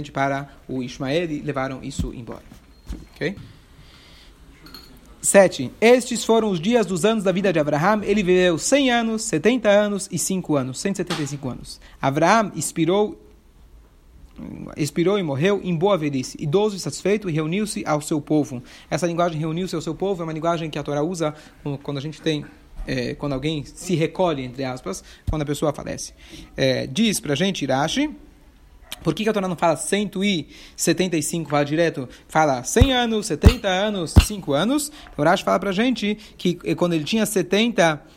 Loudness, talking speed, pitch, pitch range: -21 LUFS, 170 wpm, 170 Hz, 145-200 Hz